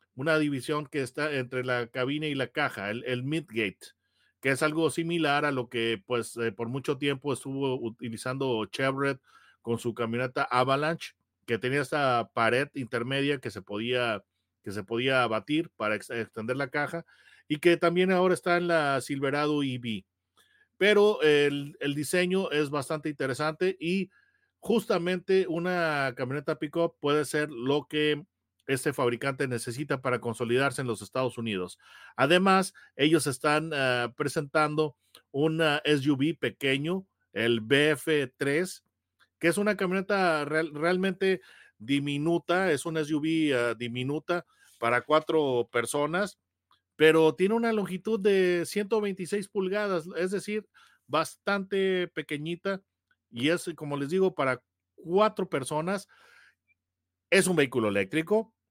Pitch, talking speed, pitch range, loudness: 150 Hz, 135 wpm, 125-175 Hz, -28 LUFS